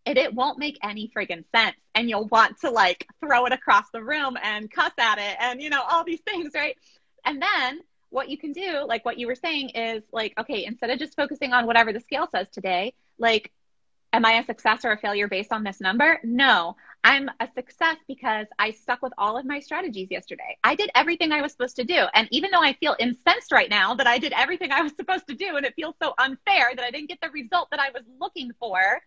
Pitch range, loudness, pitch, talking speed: 225-300 Hz, -23 LUFS, 255 Hz, 245 wpm